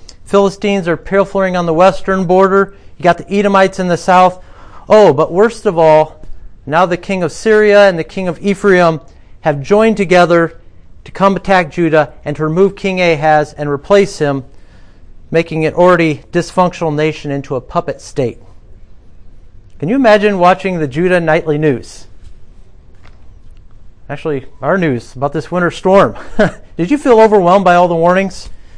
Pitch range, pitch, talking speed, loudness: 135-190 Hz, 165 Hz, 160 wpm, -12 LUFS